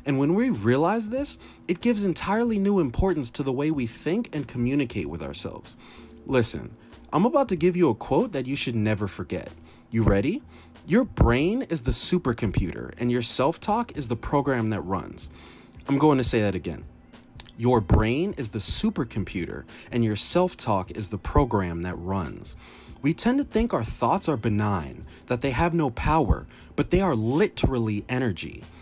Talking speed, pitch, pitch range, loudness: 180 wpm, 120 Hz, 105-150 Hz, -25 LUFS